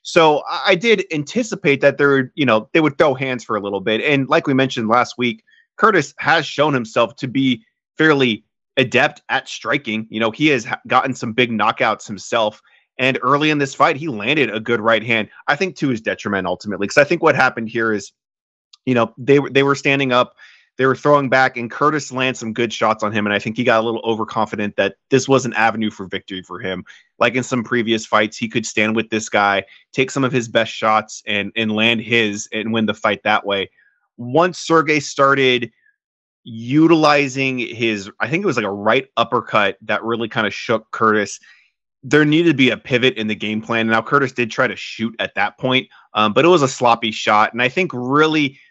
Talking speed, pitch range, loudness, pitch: 220 wpm, 110-140 Hz, -17 LUFS, 120 Hz